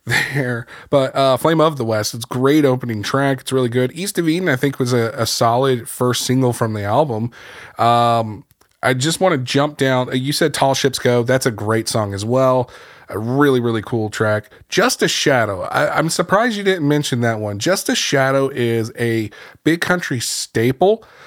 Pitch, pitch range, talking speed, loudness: 130 Hz, 115-145 Hz, 195 wpm, -17 LUFS